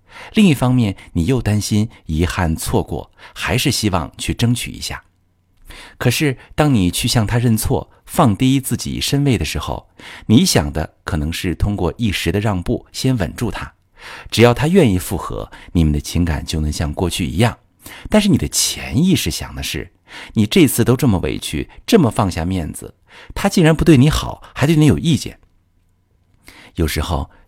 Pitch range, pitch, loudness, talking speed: 85-125 Hz, 100 Hz, -17 LUFS, 250 characters per minute